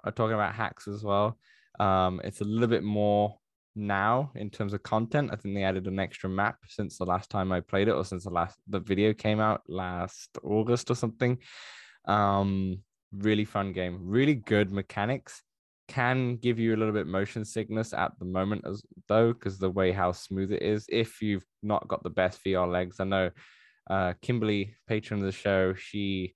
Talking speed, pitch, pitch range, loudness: 200 wpm, 100 Hz, 95-110 Hz, -29 LUFS